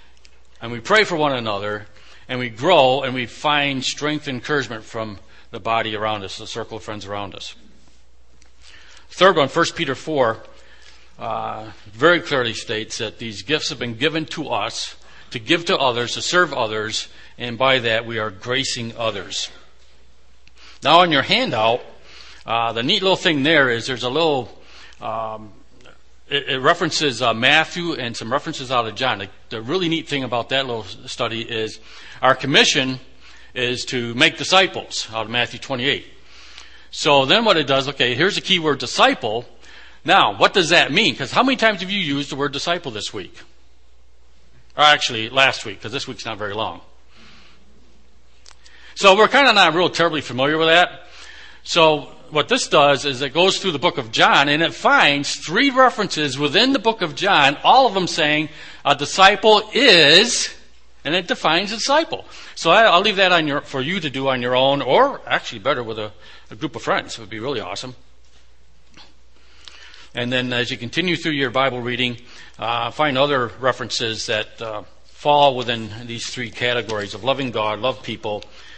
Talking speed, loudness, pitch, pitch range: 180 wpm, -18 LUFS, 125 Hz, 110-150 Hz